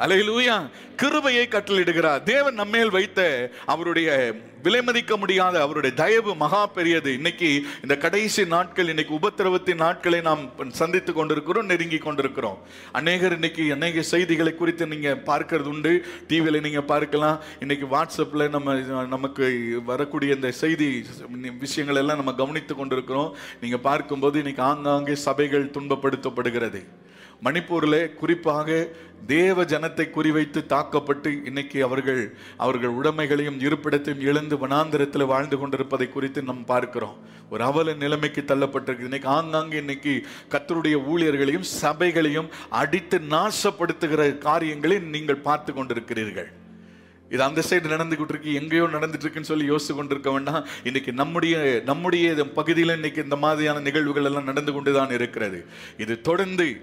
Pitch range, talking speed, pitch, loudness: 140-165 Hz, 120 wpm, 150 Hz, -23 LUFS